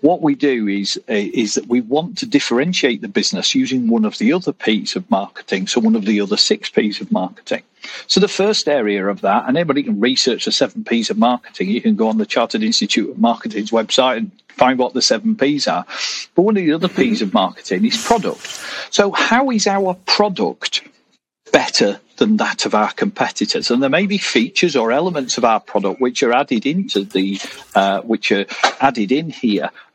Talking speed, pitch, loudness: 205 wpm, 155 Hz, -17 LUFS